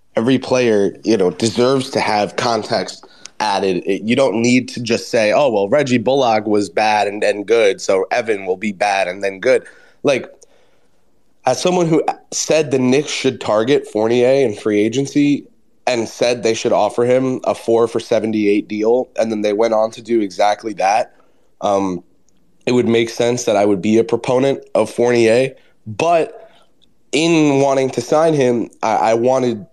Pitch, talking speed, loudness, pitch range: 120 Hz, 180 wpm, -16 LUFS, 110-135 Hz